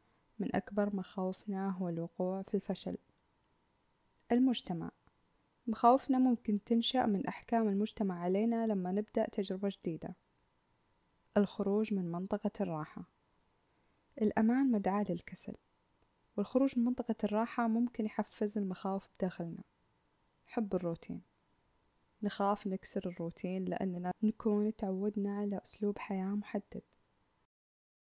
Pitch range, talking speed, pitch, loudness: 185-220 Hz, 100 wpm, 205 Hz, -35 LUFS